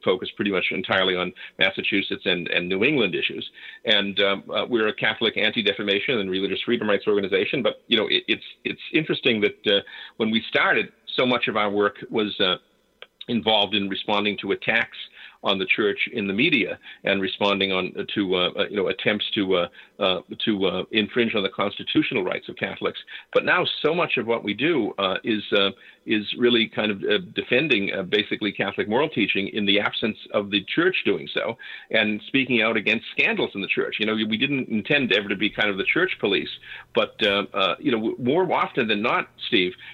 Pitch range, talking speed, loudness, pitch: 100-120 Hz, 200 wpm, -23 LUFS, 105 Hz